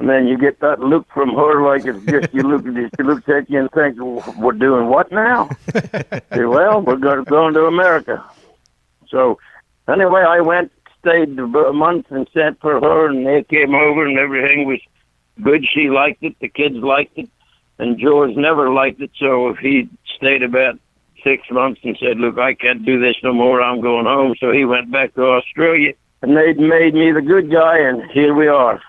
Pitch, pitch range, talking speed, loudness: 140 Hz, 130-155 Hz, 210 wpm, -14 LUFS